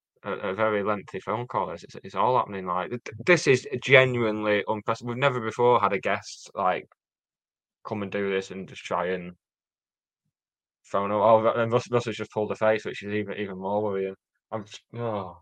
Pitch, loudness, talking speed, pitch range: 105 Hz, -26 LUFS, 190 wpm, 100-115 Hz